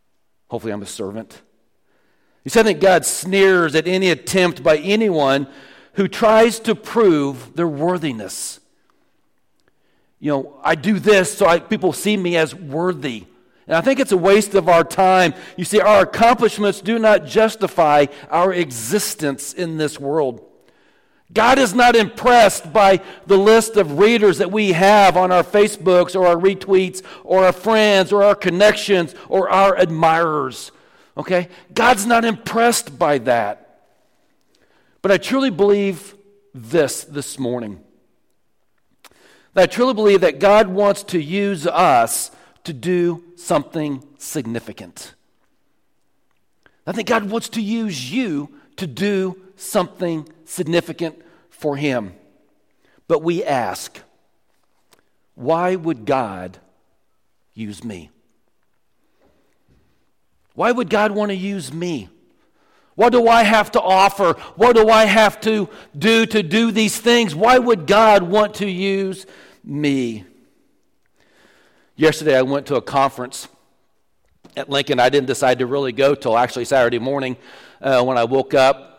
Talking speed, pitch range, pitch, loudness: 140 wpm, 150-210 Hz, 185 Hz, -16 LUFS